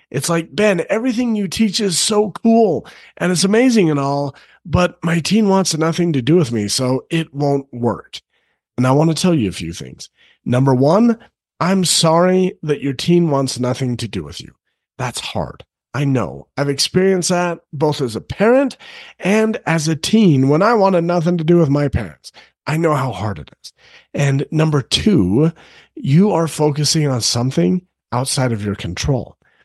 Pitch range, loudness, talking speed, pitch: 135-185 Hz, -16 LUFS, 185 wpm, 160 Hz